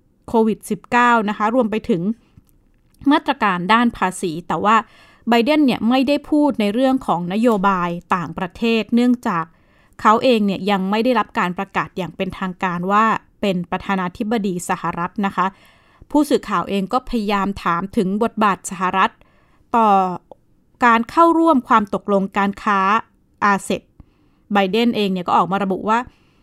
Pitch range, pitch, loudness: 190-235 Hz, 210 Hz, -18 LUFS